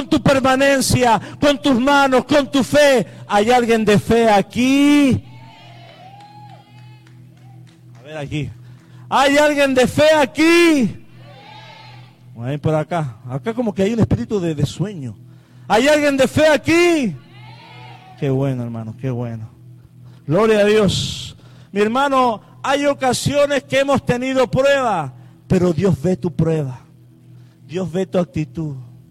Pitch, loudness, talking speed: 165 Hz, -16 LUFS, 130 wpm